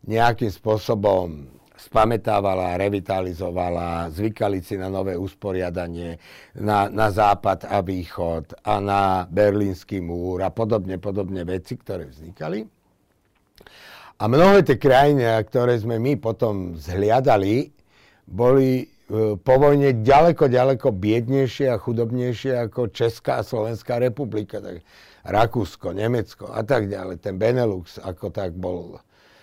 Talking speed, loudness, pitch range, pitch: 120 wpm, -21 LUFS, 95-120 Hz, 100 Hz